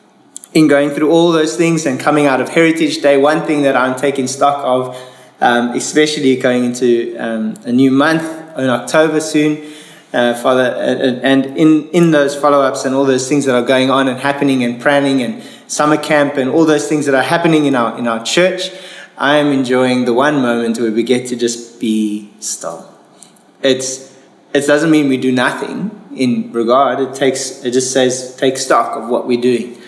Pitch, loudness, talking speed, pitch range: 135 Hz, -13 LUFS, 195 wpm, 125-150 Hz